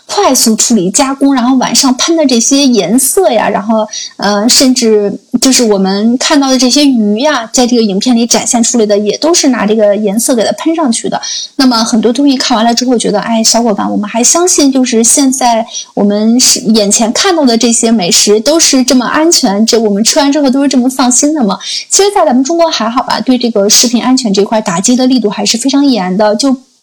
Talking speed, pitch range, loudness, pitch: 330 characters per minute, 220-275 Hz, -8 LUFS, 245 Hz